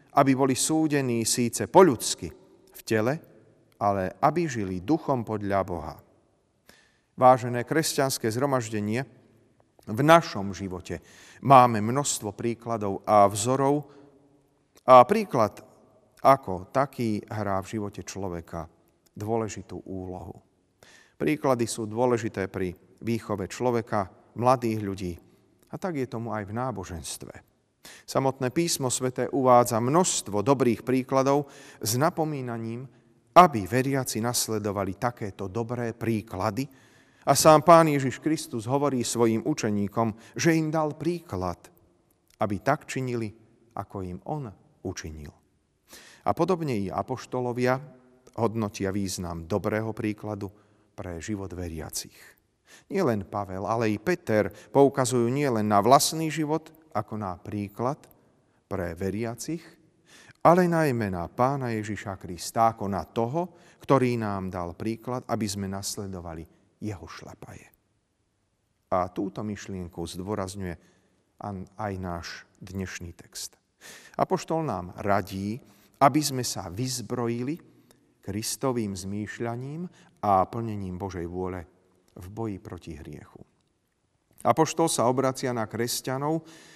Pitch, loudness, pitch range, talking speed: 115 Hz, -26 LUFS, 100-130 Hz, 110 wpm